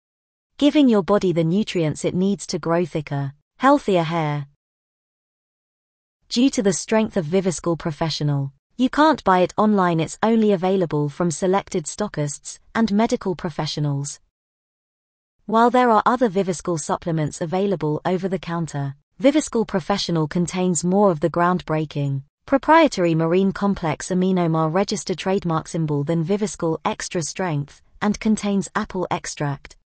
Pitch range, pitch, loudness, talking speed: 160-205 Hz, 180 Hz, -20 LUFS, 130 wpm